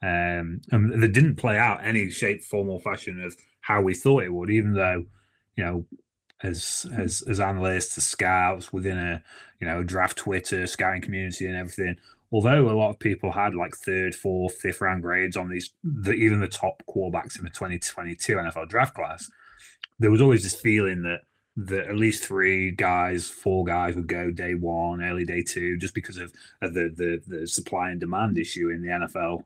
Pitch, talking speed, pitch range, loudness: 95 Hz, 200 wpm, 90-105 Hz, -25 LUFS